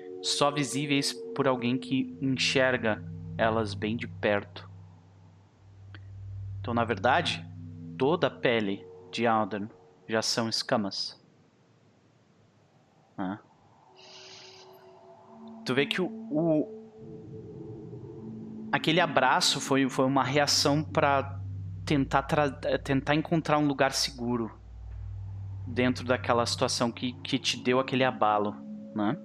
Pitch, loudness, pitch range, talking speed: 115 Hz, -28 LUFS, 95-135 Hz, 105 wpm